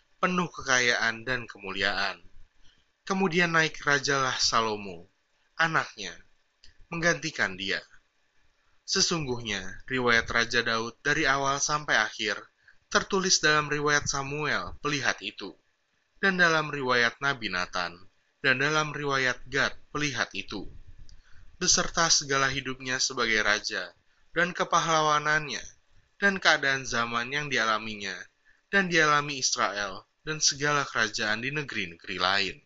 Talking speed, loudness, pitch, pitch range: 105 wpm, -26 LUFS, 140 Hz, 115-155 Hz